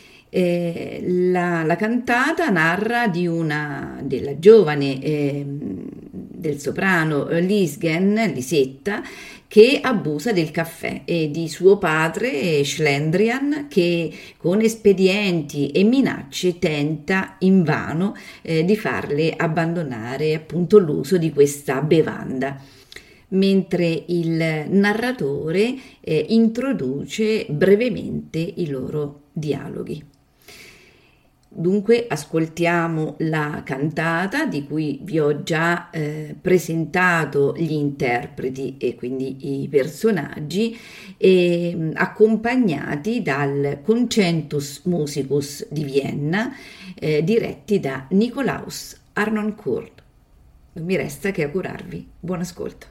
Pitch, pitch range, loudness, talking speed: 170 Hz, 150-205 Hz, -20 LUFS, 95 wpm